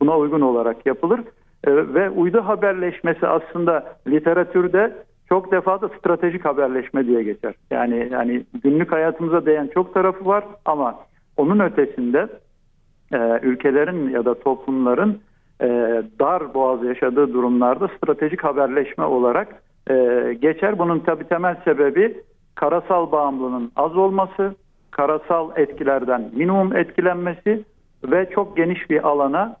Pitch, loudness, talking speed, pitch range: 165 Hz, -20 LUFS, 120 wpm, 135-190 Hz